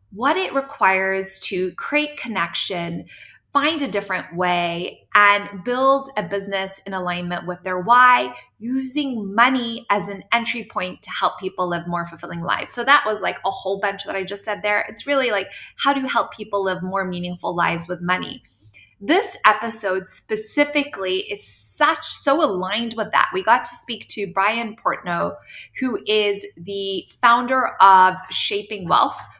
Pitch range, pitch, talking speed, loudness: 185-245 Hz, 200 Hz, 165 wpm, -20 LUFS